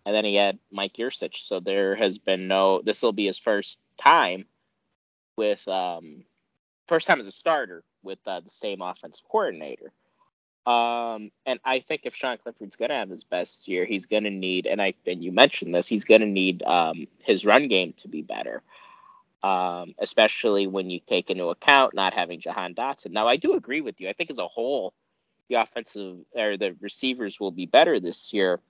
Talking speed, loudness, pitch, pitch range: 195 wpm, -24 LUFS, 105 Hz, 95-130 Hz